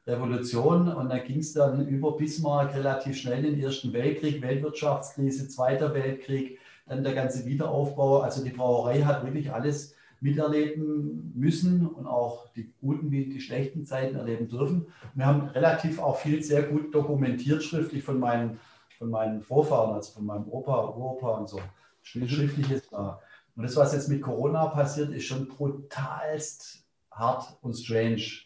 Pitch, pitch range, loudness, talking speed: 135 Hz, 125-150 Hz, -28 LUFS, 160 wpm